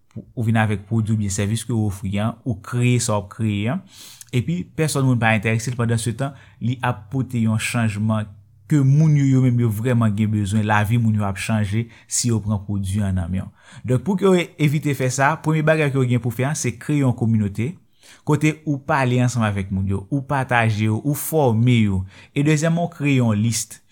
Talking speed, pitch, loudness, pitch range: 235 wpm, 115 Hz, -20 LUFS, 110-135 Hz